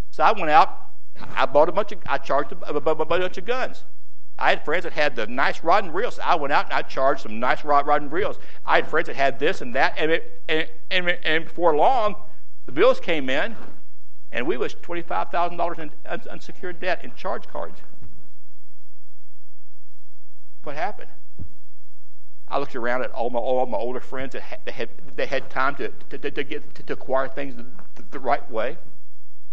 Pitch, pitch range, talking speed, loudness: 150 Hz, 125-175 Hz, 210 wpm, -24 LUFS